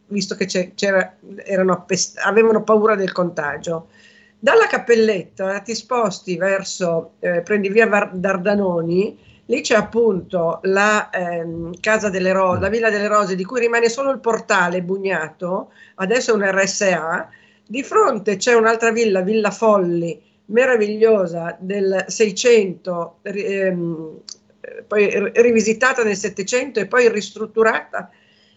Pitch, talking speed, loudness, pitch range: 205 Hz, 125 wpm, -18 LUFS, 185-225 Hz